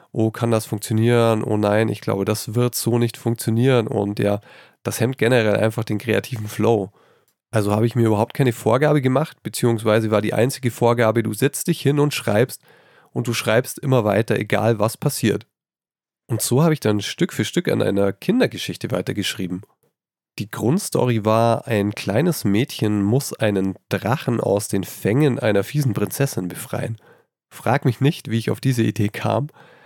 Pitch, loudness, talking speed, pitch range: 115 Hz, -20 LUFS, 175 wpm, 105-125 Hz